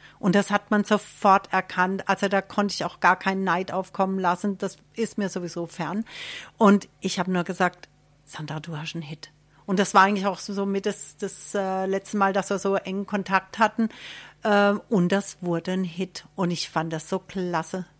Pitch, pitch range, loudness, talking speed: 190 Hz, 175-200 Hz, -25 LUFS, 195 wpm